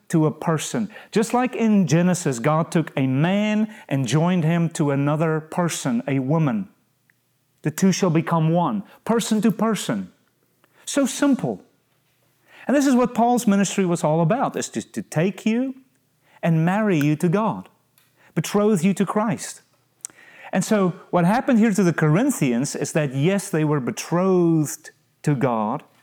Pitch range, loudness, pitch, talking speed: 155-215 Hz, -21 LUFS, 175 Hz, 155 wpm